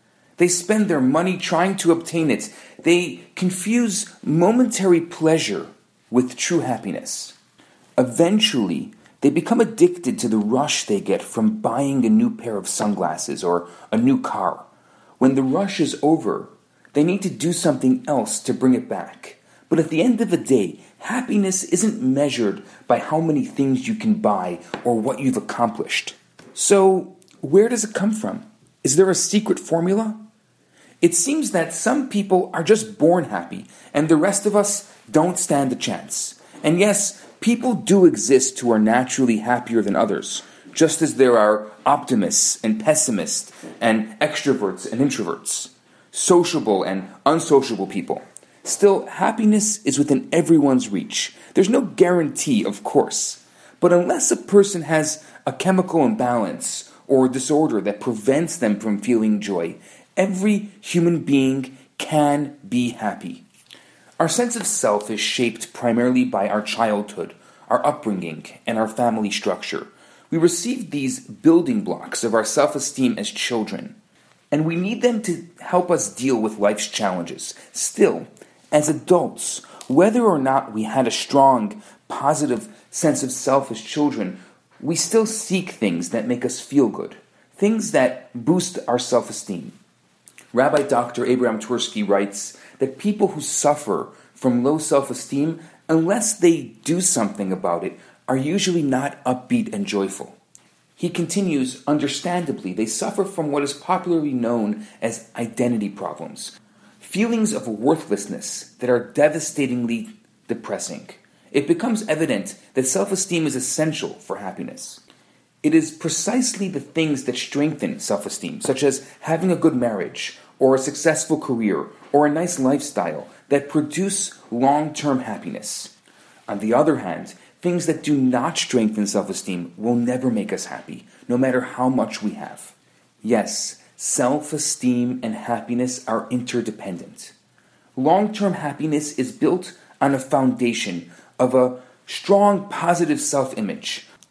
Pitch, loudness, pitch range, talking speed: 155 Hz, -20 LUFS, 125-190 Hz, 145 wpm